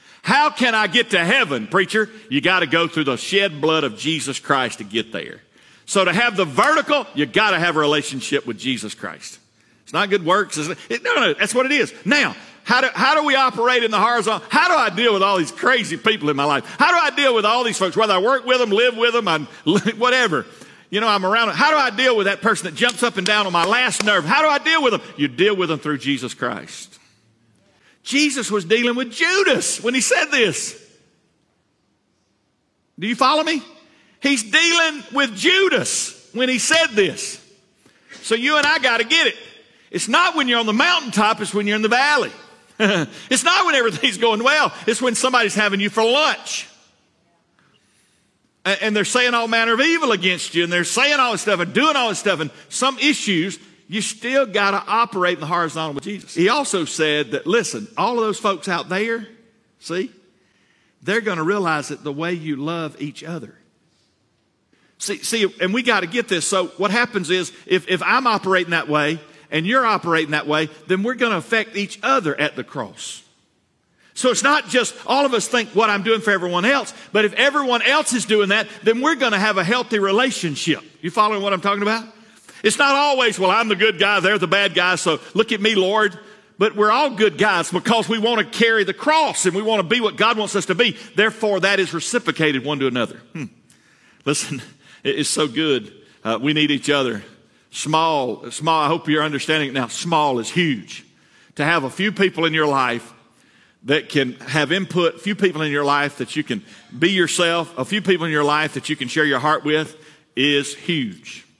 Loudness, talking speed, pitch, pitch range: -18 LUFS, 215 wpm, 205 Hz, 165-240 Hz